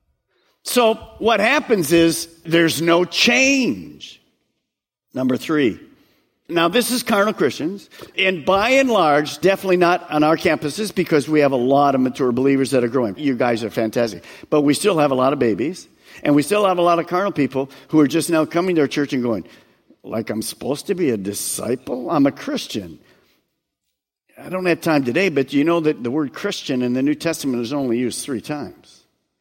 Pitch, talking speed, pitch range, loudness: 150 Hz, 195 wpm, 130-180 Hz, -18 LUFS